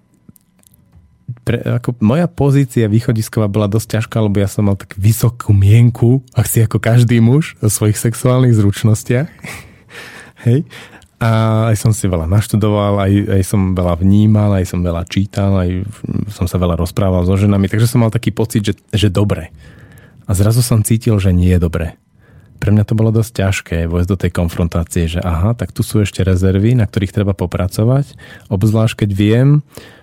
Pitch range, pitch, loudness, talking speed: 95-115 Hz, 105 Hz, -14 LUFS, 175 wpm